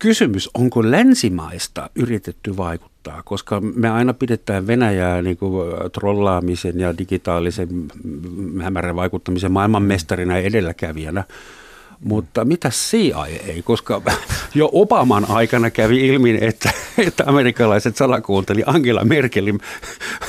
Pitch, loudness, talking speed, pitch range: 100 Hz, -18 LUFS, 110 wpm, 90-120 Hz